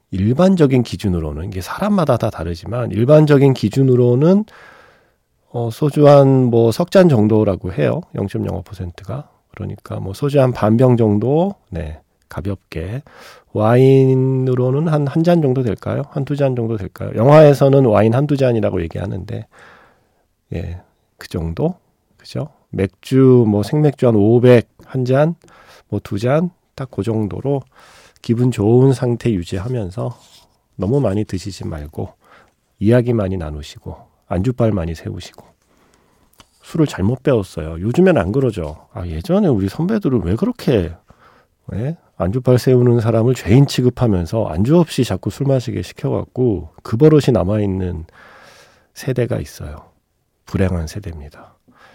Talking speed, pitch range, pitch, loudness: 280 characters per minute, 100-135 Hz, 115 Hz, -16 LUFS